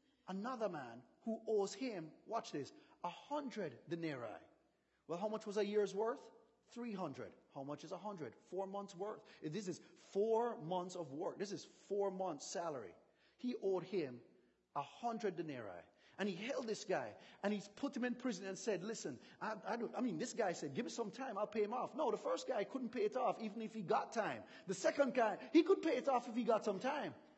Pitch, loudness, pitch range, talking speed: 215 Hz, -42 LUFS, 195-240 Hz, 220 wpm